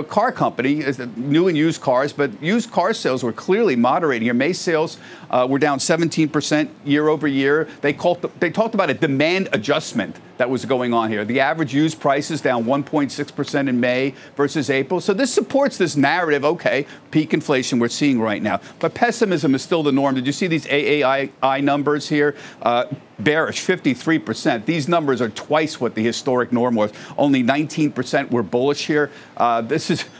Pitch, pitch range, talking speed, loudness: 145 Hz, 130-160 Hz, 185 wpm, -19 LUFS